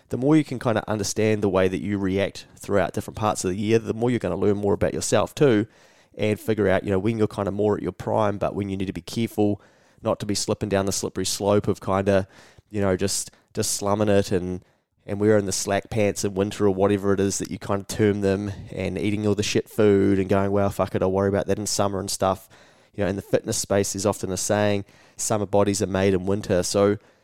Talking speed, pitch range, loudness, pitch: 260 wpm, 95-105 Hz, -23 LUFS, 100 Hz